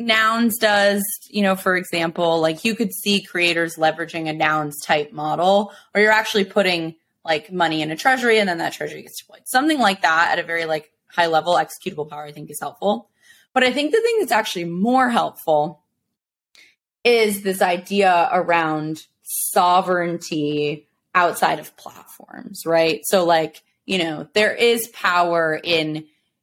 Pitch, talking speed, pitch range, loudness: 175 Hz, 165 wpm, 160-210 Hz, -19 LUFS